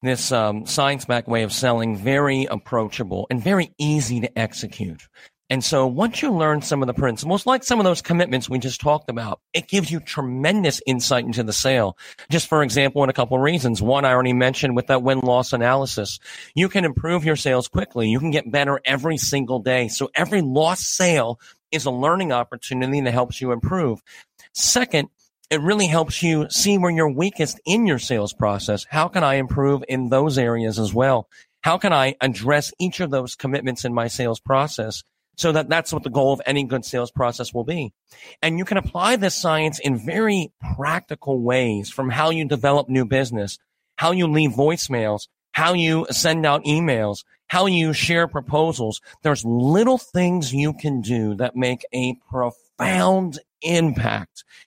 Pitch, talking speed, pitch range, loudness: 135 Hz, 185 wpm, 125-160 Hz, -21 LUFS